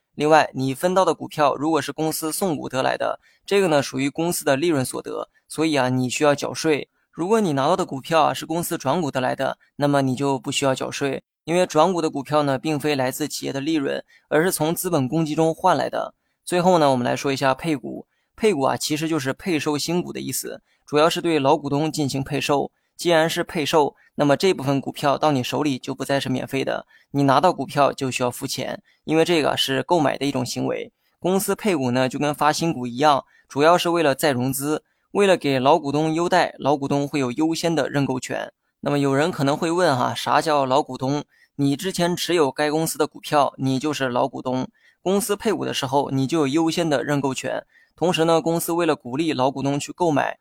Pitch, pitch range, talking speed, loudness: 150 Hz, 135-165 Hz, 325 characters per minute, -22 LUFS